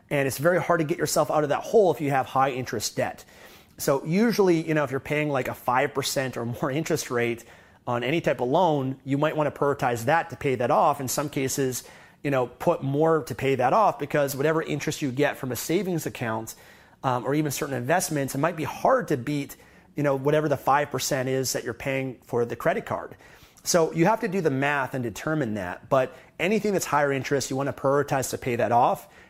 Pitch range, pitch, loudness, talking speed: 130-155 Hz, 140 Hz, -25 LUFS, 230 wpm